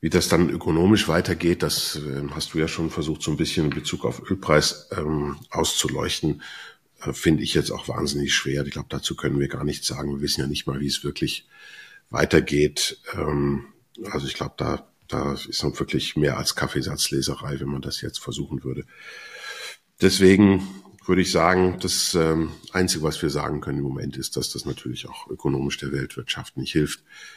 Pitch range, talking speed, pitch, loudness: 70-85 Hz, 185 wpm, 75 Hz, -24 LUFS